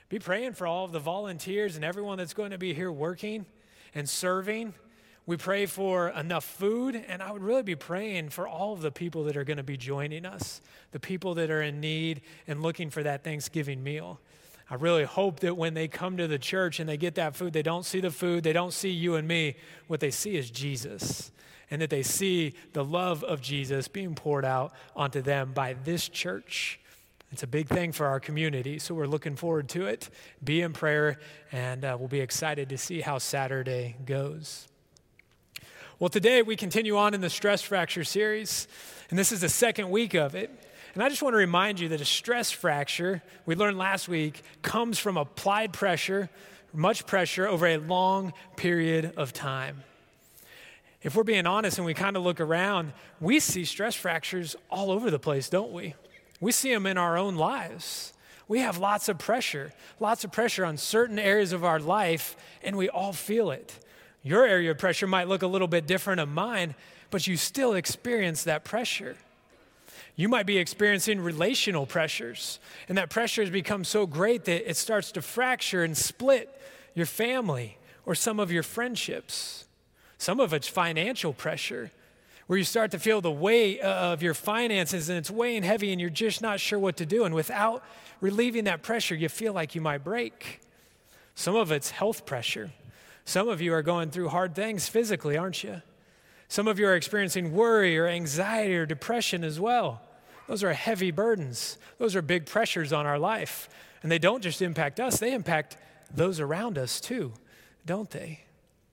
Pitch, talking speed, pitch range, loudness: 175 Hz, 195 wpm, 155-205 Hz, -28 LUFS